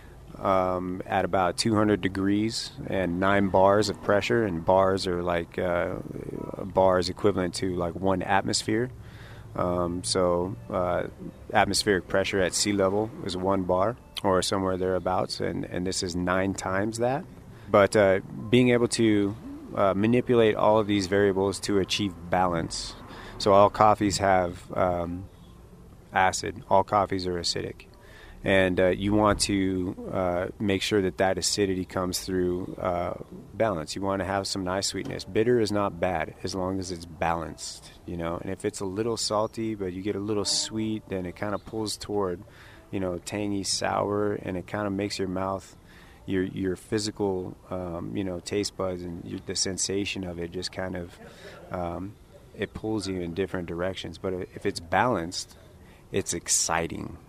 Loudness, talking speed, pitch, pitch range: -26 LUFS, 165 wpm, 95 Hz, 90-105 Hz